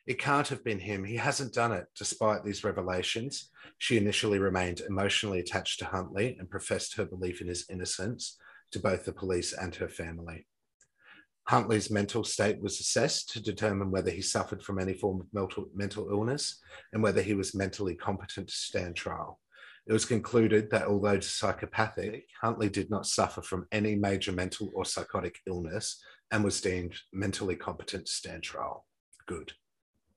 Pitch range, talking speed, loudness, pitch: 95-110 Hz, 165 wpm, -32 LUFS, 100 Hz